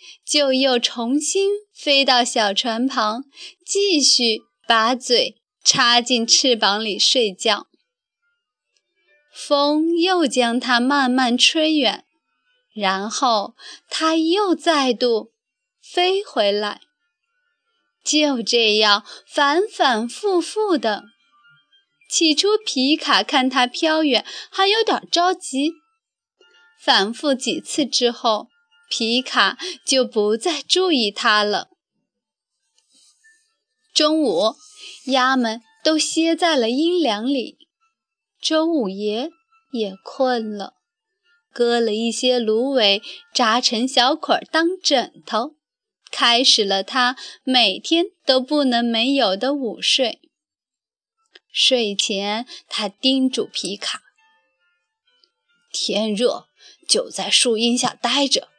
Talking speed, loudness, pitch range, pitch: 135 characters per minute, -18 LUFS, 235-355 Hz, 275 Hz